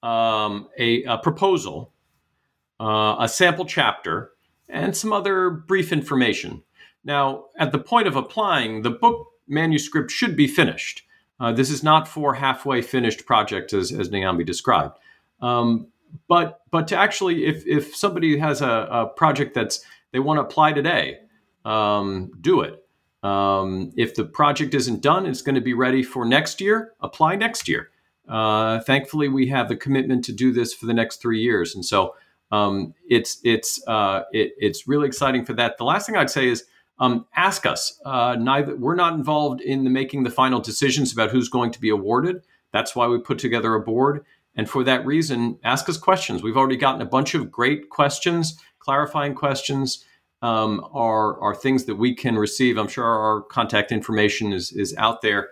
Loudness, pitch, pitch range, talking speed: -21 LUFS, 130 Hz, 115-150 Hz, 180 wpm